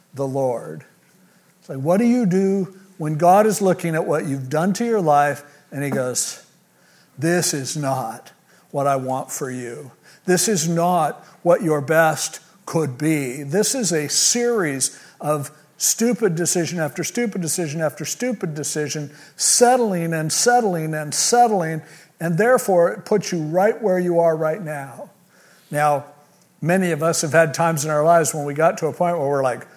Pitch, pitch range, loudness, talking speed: 165 Hz, 150-185 Hz, -20 LUFS, 175 wpm